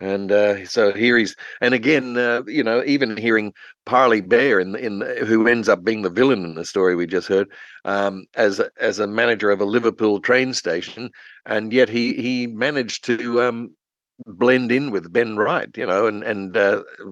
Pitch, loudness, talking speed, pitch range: 115 Hz, -19 LUFS, 195 wpm, 100-125 Hz